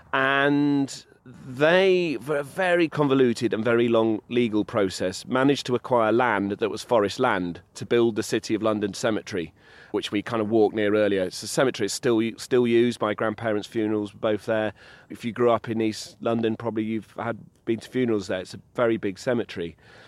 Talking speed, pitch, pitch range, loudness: 195 wpm, 115 Hz, 105-125 Hz, -24 LUFS